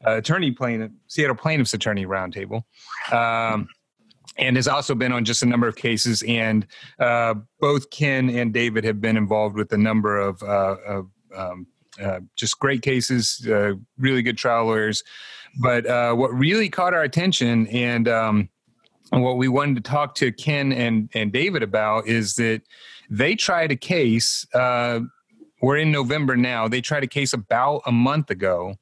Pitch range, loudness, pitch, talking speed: 110-130 Hz, -21 LUFS, 120 Hz, 175 wpm